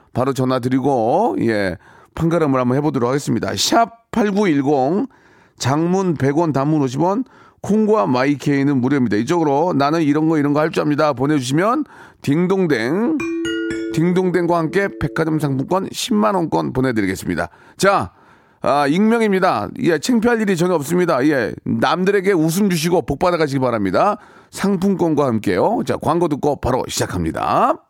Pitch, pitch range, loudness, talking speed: 160 Hz, 135-185 Hz, -18 LUFS, 320 characters per minute